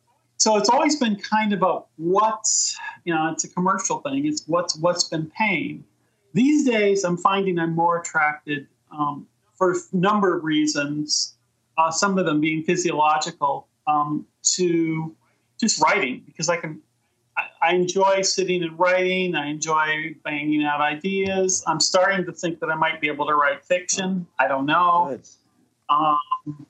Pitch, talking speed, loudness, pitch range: 170 Hz, 160 wpm, -21 LUFS, 150-190 Hz